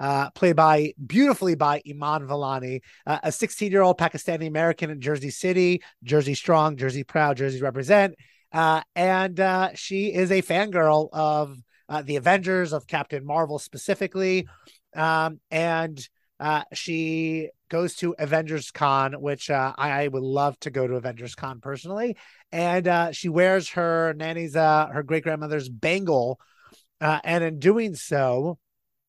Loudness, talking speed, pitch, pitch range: -24 LUFS, 155 wpm, 160 Hz, 145-175 Hz